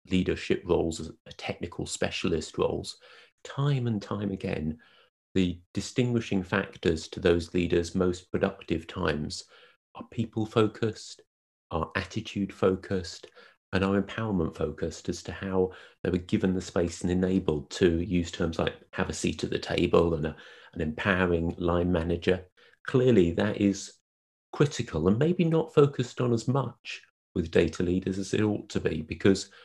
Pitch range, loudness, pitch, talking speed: 85-105 Hz, -29 LUFS, 95 Hz, 155 wpm